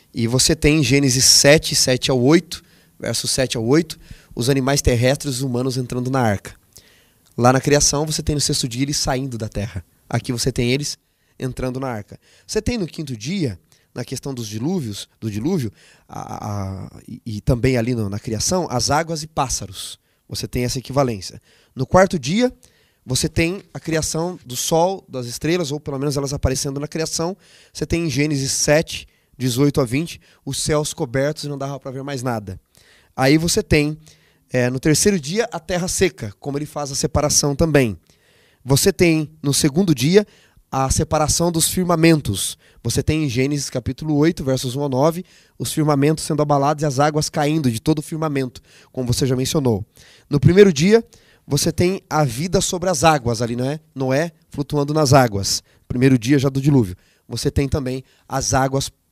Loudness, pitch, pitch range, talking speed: -19 LUFS, 140 Hz, 125-155 Hz, 185 wpm